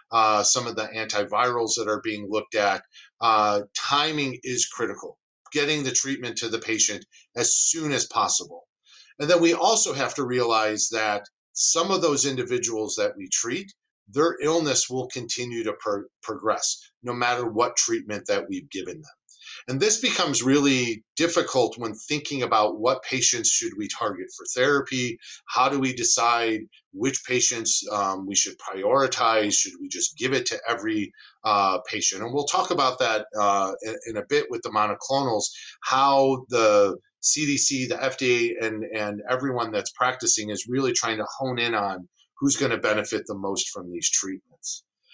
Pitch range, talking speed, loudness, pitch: 110-150 Hz, 165 wpm, -24 LUFS, 125 Hz